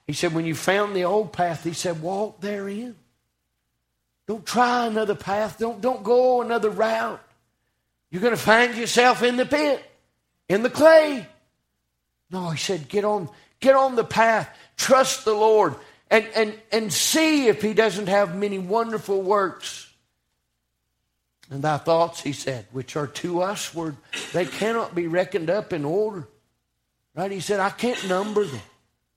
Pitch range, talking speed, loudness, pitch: 165-225 Hz, 160 wpm, -22 LUFS, 200 Hz